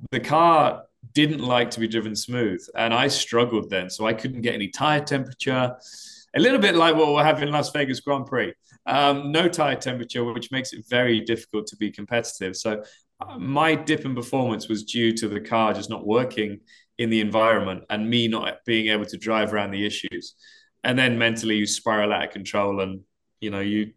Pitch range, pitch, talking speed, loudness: 105-130 Hz, 115 Hz, 205 wpm, -23 LUFS